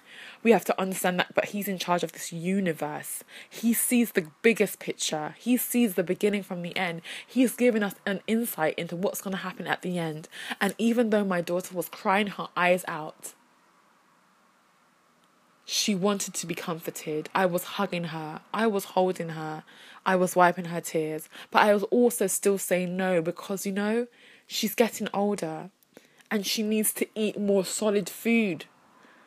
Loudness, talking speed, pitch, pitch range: -27 LUFS, 175 wpm, 190 Hz, 175-215 Hz